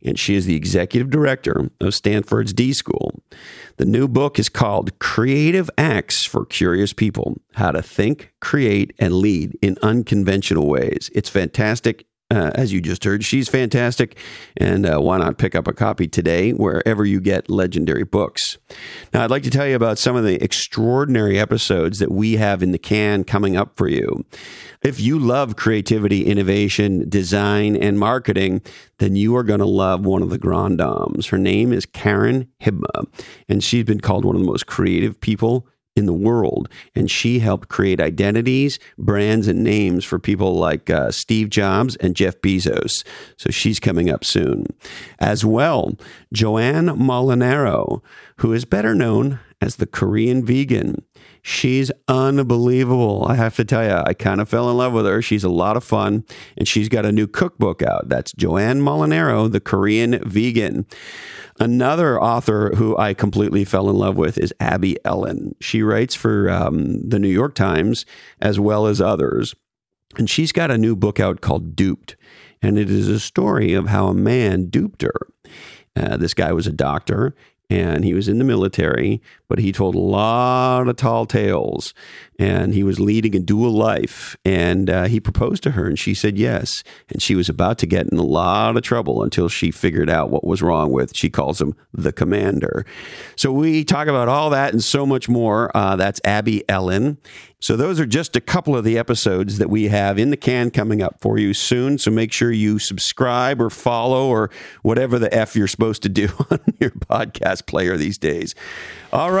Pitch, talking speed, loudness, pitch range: 110 Hz, 185 wpm, -18 LUFS, 100-120 Hz